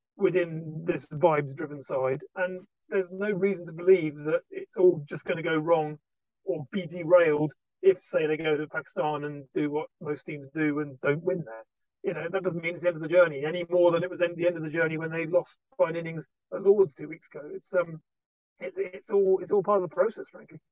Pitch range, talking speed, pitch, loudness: 155-185 Hz, 230 wpm, 170 Hz, -28 LUFS